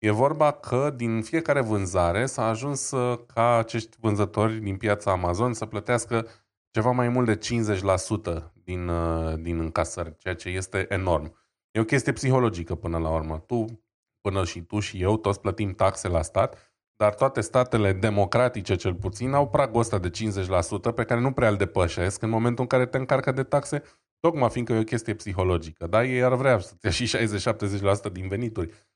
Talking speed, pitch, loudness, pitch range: 180 wpm, 110 Hz, -25 LUFS, 95-120 Hz